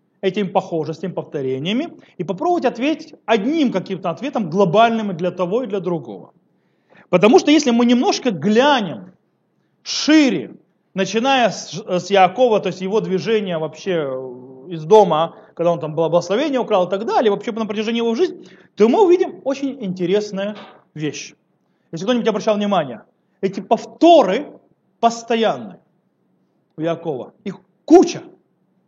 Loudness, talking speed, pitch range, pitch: -18 LUFS, 130 wpm, 180-240 Hz, 205 Hz